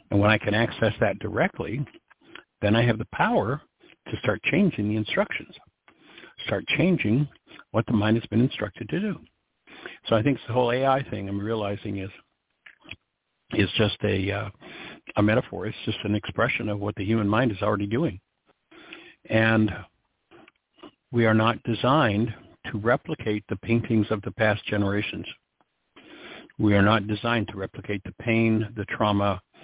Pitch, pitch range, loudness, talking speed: 110 Hz, 105-120 Hz, -25 LUFS, 160 wpm